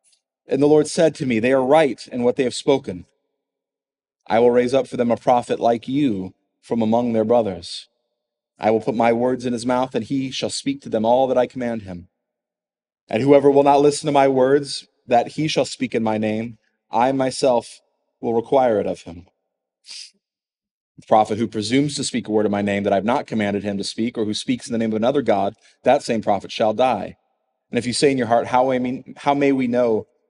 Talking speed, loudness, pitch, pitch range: 225 wpm, -19 LUFS, 120 Hz, 110-135 Hz